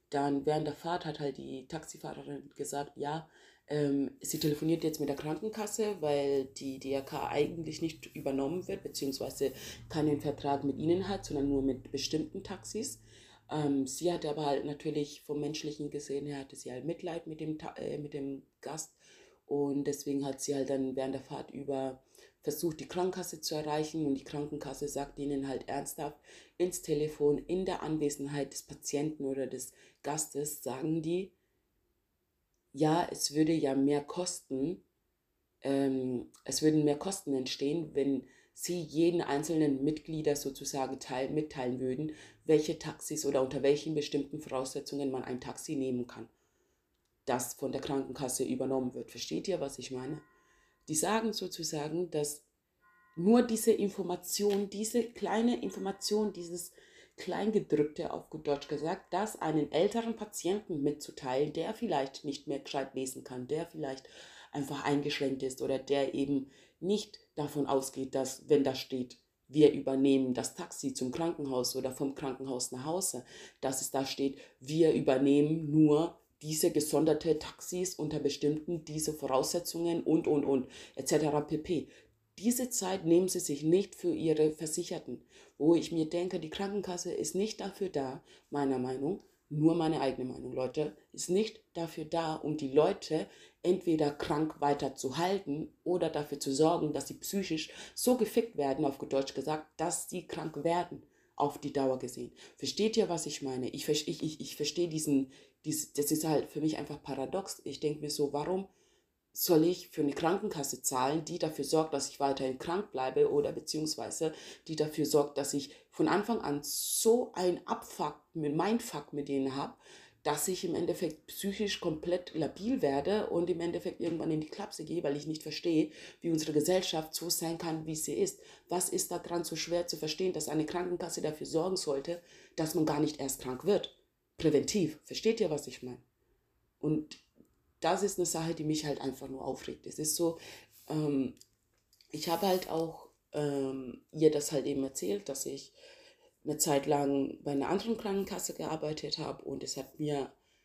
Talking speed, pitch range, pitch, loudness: 165 wpm, 140-170 Hz, 150 Hz, -34 LUFS